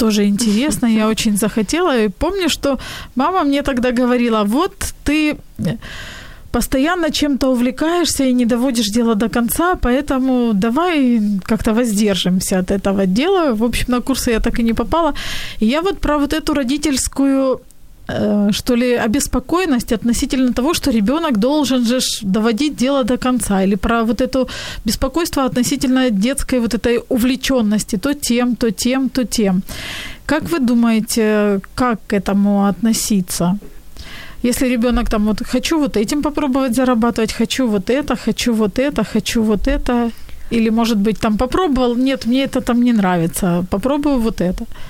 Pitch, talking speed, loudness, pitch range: 245 Hz, 150 wpm, -16 LUFS, 220-270 Hz